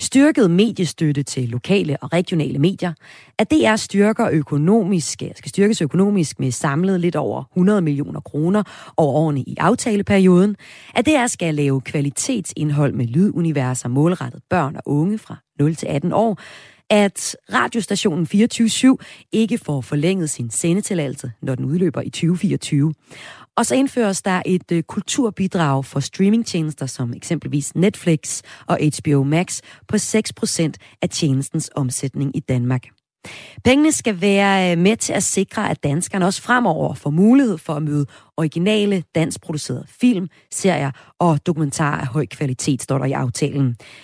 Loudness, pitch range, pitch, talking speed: -19 LUFS, 145-200 Hz, 165 Hz, 145 wpm